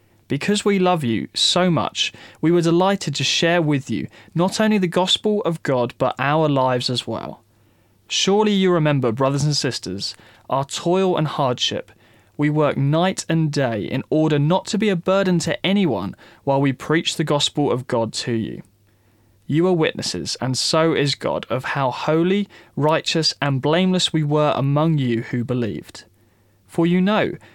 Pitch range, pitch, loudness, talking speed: 120-175 Hz, 150 Hz, -20 LUFS, 170 wpm